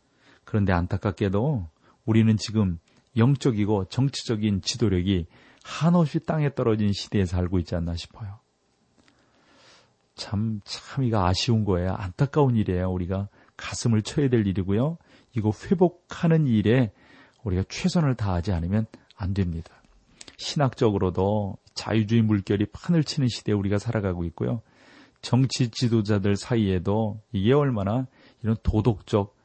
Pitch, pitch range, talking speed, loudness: 110 Hz, 95-125 Hz, 305 characters per minute, -25 LUFS